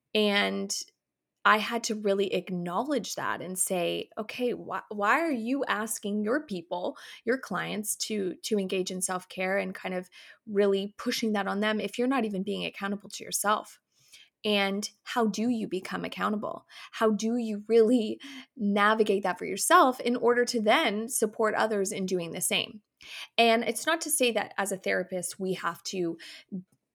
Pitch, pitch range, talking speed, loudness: 210 Hz, 190-230 Hz, 170 wpm, -28 LUFS